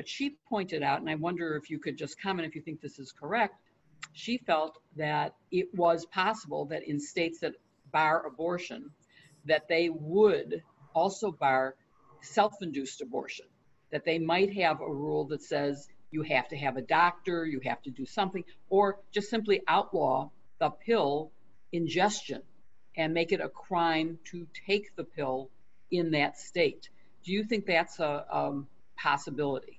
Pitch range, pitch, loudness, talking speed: 145-185 Hz, 160 Hz, -31 LUFS, 165 wpm